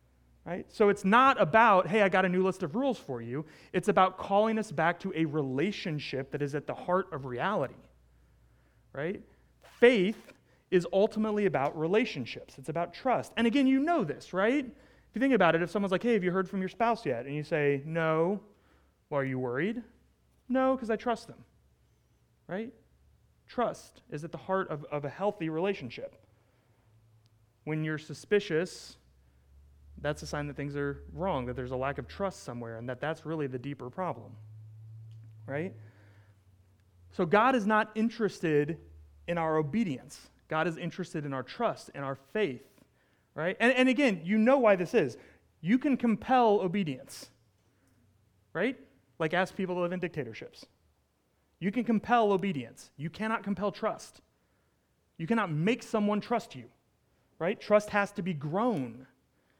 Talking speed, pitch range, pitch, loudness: 170 wpm, 125-205 Hz, 160 Hz, -30 LUFS